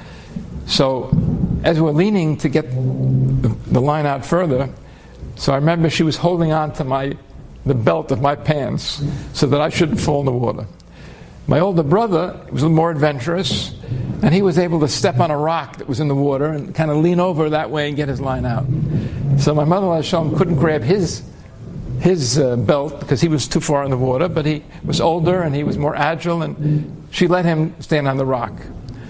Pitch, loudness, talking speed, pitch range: 150 Hz, -18 LUFS, 210 wpm, 135-165 Hz